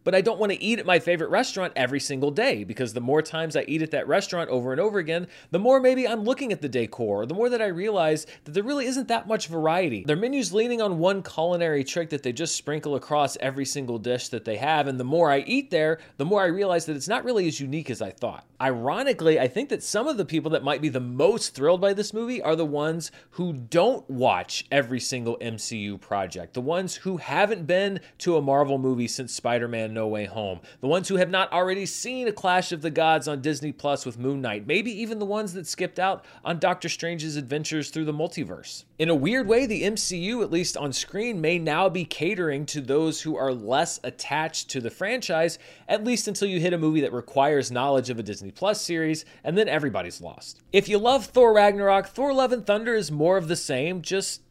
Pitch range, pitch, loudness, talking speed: 140-195 Hz, 160 Hz, -25 LUFS, 235 wpm